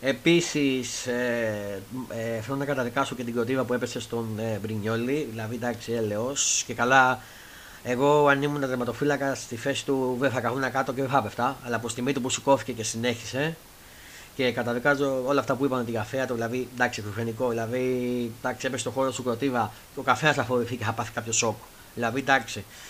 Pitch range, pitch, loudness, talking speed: 115-135 Hz, 125 Hz, -26 LUFS, 190 wpm